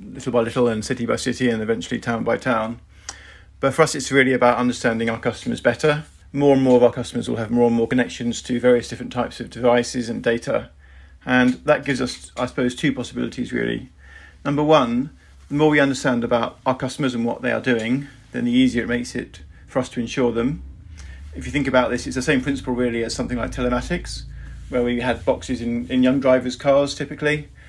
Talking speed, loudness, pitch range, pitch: 215 wpm, -21 LUFS, 120-130 Hz, 125 Hz